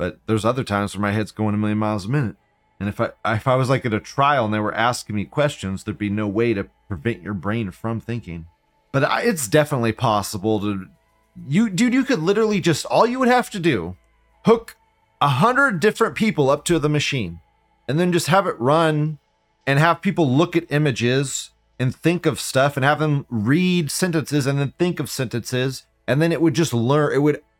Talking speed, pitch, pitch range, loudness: 215 wpm, 135 Hz, 110-165 Hz, -20 LUFS